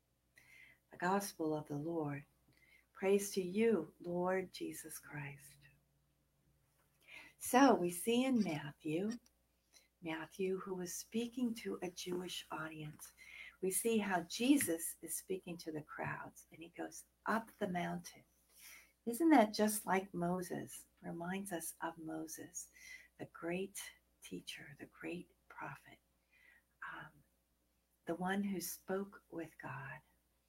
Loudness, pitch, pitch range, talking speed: -39 LUFS, 175 Hz, 155-200 Hz, 120 wpm